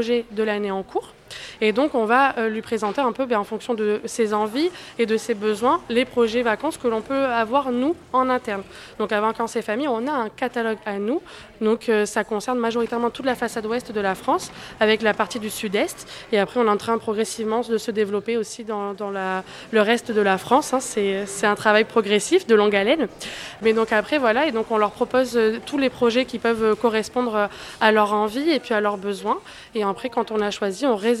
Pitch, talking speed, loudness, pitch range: 225 Hz, 225 wpm, -22 LUFS, 210-240 Hz